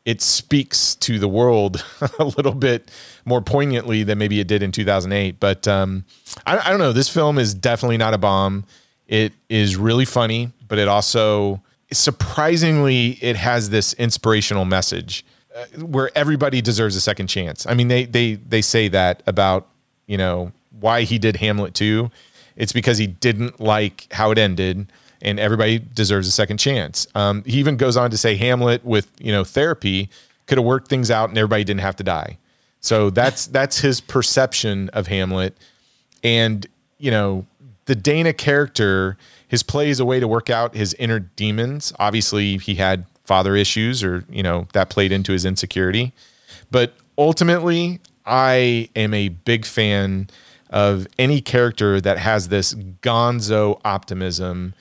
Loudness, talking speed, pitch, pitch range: -19 LUFS, 165 wpm, 110 Hz, 100-125 Hz